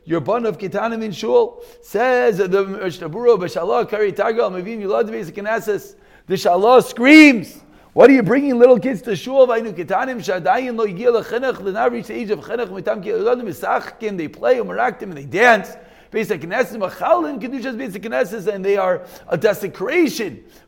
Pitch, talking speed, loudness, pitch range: 230 Hz, 180 wpm, -17 LUFS, 200-255 Hz